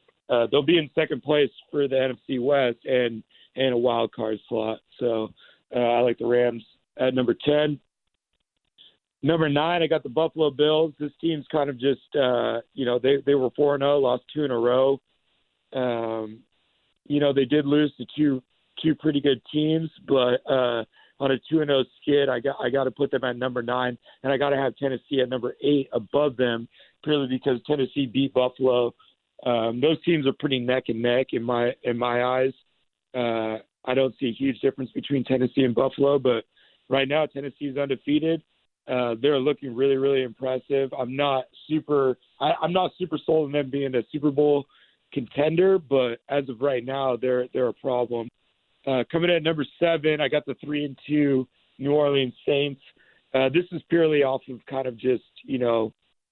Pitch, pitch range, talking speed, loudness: 135 Hz, 125-145 Hz, 195 wpm, -24 LUFS